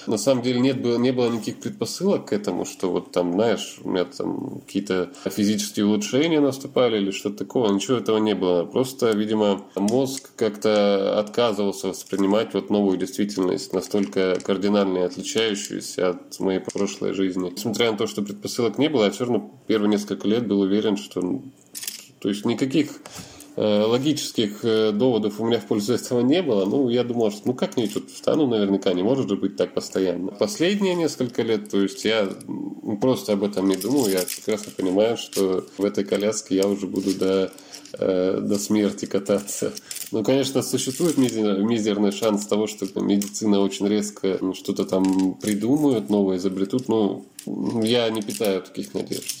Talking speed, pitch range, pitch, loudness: 160 wpm, 95-115 Hz, 105 Hz, -23 LUFS